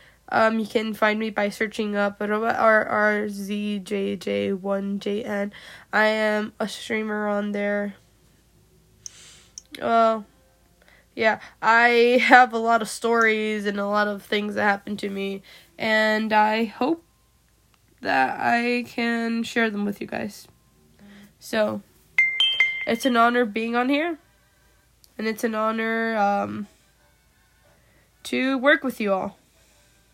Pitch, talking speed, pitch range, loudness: 215 Hz, 135 wpm, 205-230 Hz, -22 LUFS